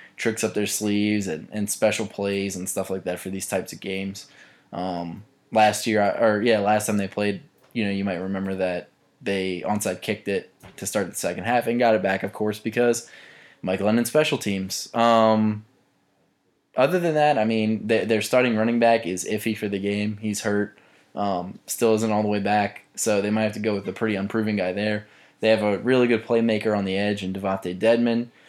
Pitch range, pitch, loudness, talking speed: 95-110 Hz, 105 Hz, -23 LUFS, 210 wpm